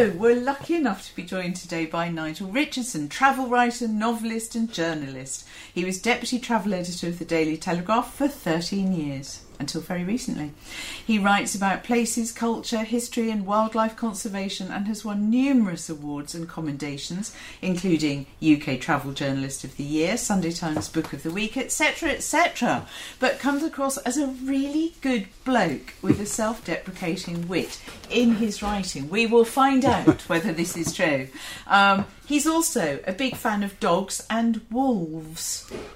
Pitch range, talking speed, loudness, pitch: 165-240 Hz, 160 wpm, -25 LUFS, 205 Hz